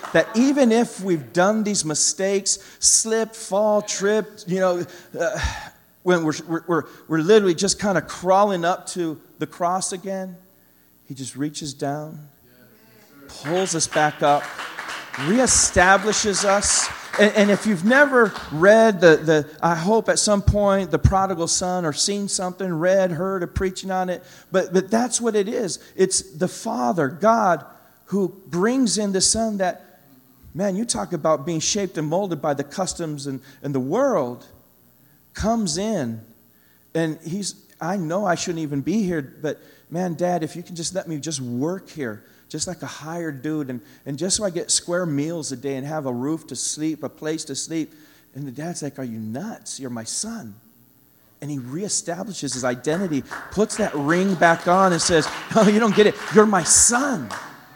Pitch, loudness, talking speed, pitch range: 175 Hz, -21 LUFS, 180 wpm, 150-195 Hz